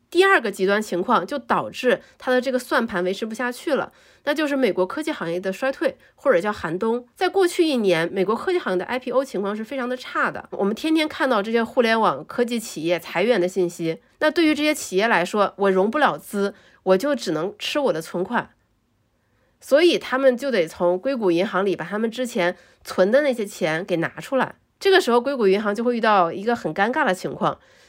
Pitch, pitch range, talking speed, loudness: 220 Hz, 180-270 Hz, 325 characters per minute, -22 LUFS